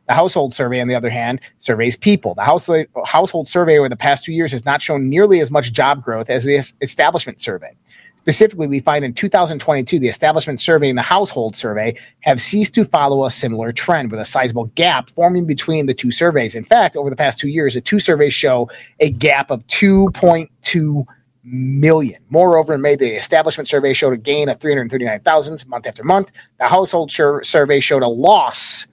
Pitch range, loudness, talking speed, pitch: 130-165 Hz, -15 LUFS, 195 wpm, 145 Hz